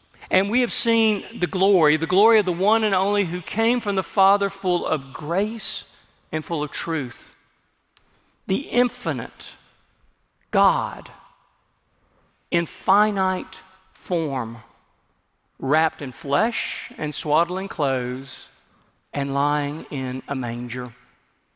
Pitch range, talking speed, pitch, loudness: 135-195 Hz, 115 wpm, 165 Hz, -23 LUFS